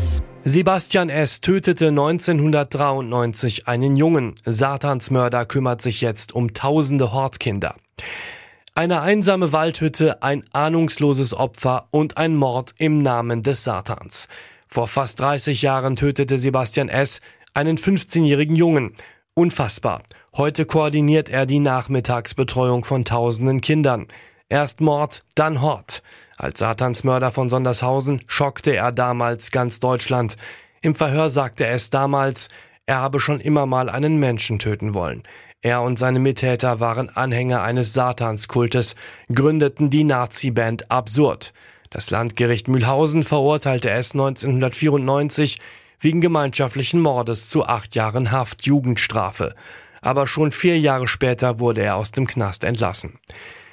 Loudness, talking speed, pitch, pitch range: -19 LUFS, 120 wpm, 135 Hz, 120-150 Hz